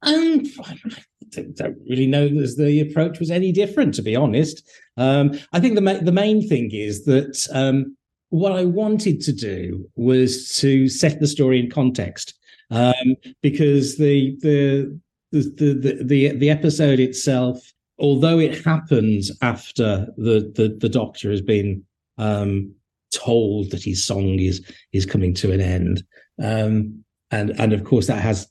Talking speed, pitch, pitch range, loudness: 160 wpm, 130 Hz, 110-150 Hz, -19 LUFS